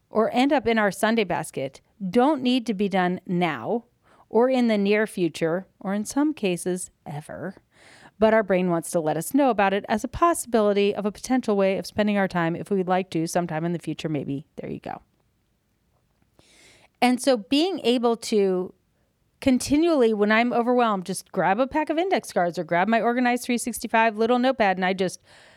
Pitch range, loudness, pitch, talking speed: 185-240 Hz, -23 LUFS, 210 Hz, 190 wpm